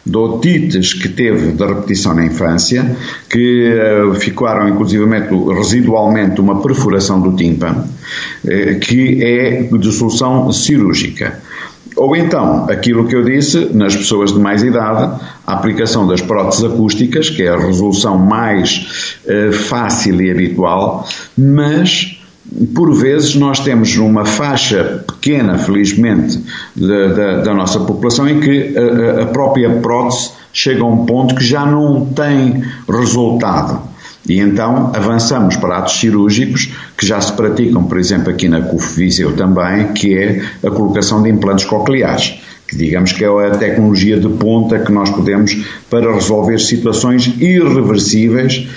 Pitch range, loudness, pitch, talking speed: 100-125 Hz, -12 LUFS, 110 Hz, 140 wpm